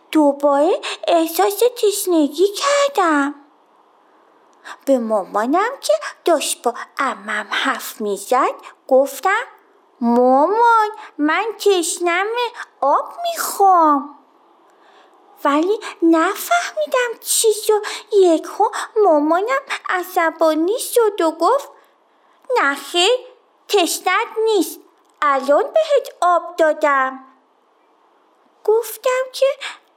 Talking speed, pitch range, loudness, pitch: 75 wpm, 300-420 Hz, -17 LUFS, 350 Hz